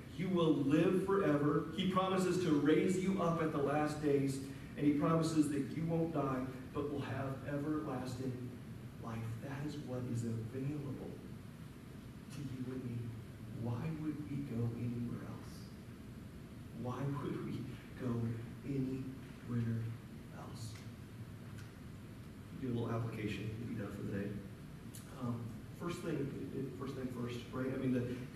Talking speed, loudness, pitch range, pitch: 145 wpm, -39 LUFS, 120-145 Hz, 130 Hz